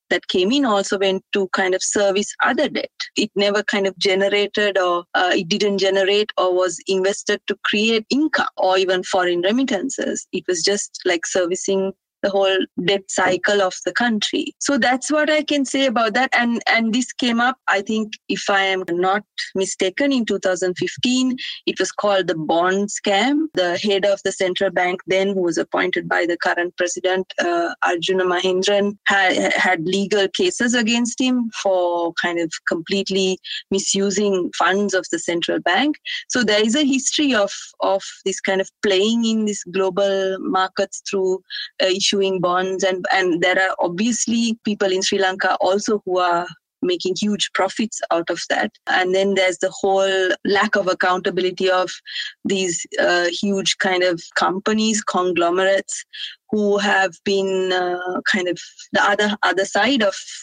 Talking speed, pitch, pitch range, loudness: 165 wpm, 195 Hz, 185-215 Hz, -19 LUFS